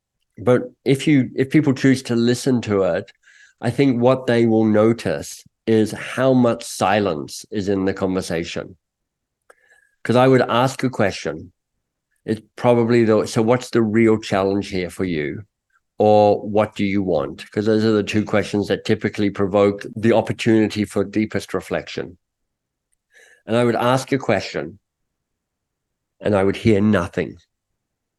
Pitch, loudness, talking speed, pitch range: 110 Hz, -19 LUFS, 150 wpm, 100-120 Hz